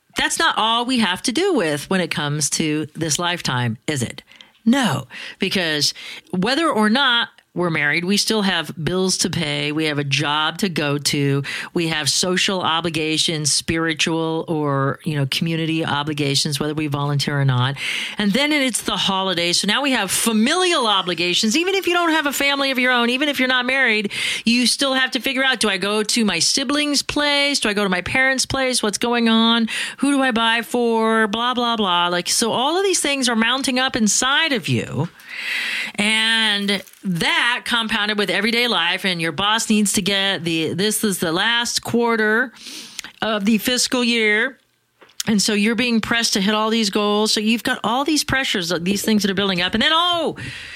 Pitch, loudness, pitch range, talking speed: 215 Hz, -18 LUFS, 170-250 Hz, 195 wpm